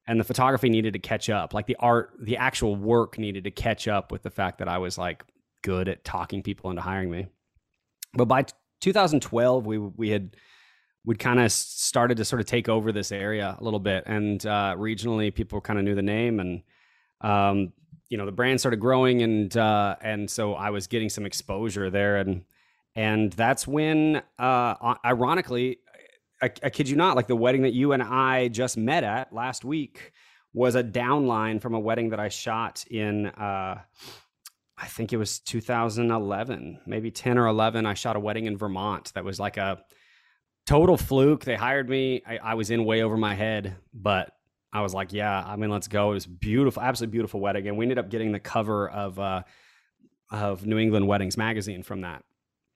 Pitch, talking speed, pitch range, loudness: 110 Hz, 200 wpm, 100-120 Hz, -26 LUFS